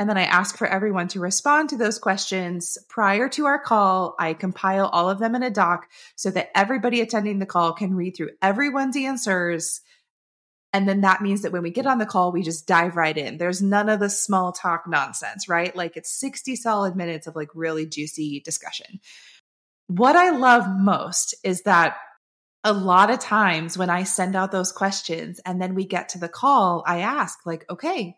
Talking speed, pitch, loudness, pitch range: 200 wpm, 190 Hz, -22 LUFS, 175-215 Hz